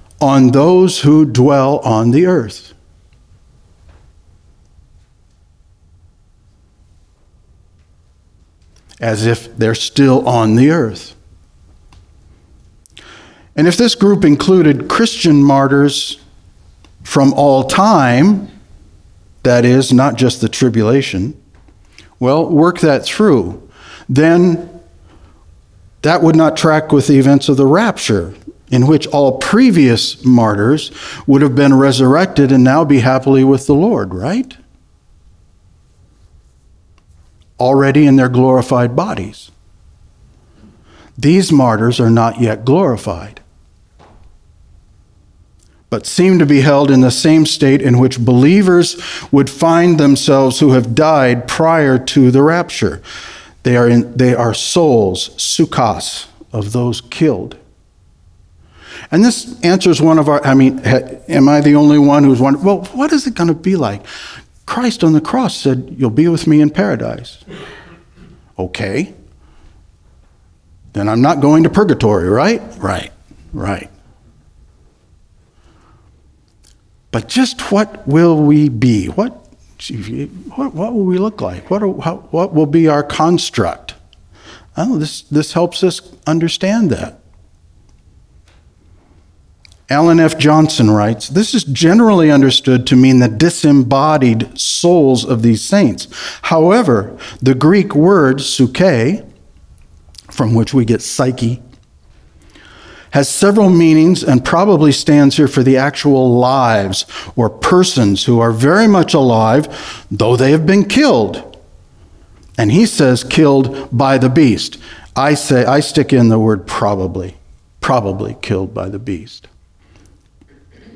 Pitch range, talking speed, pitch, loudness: 95-150 Hz, 120 wpm, 130 Hz, -11 LUFS